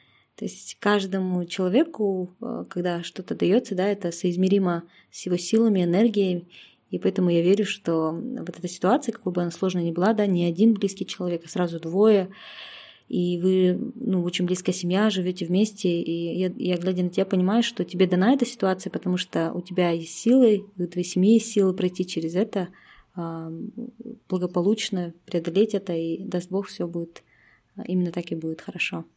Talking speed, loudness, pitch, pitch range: 170 wpm, -24 LUFS, 185 Hz, 175-205 Hz